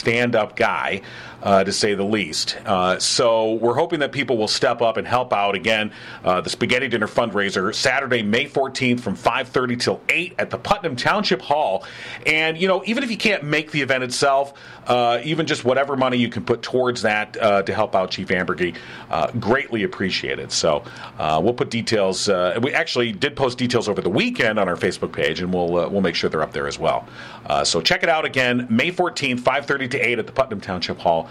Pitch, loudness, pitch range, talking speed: 125 Hz, -20 LUFS, 105-150 Hz, 215 wpm